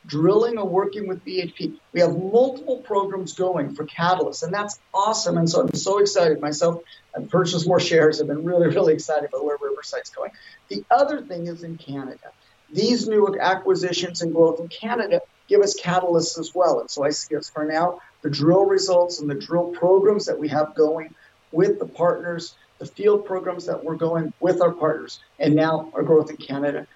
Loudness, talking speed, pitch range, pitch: -21 LUFS, 195 wpm, 160-195 Hz, 175 Hz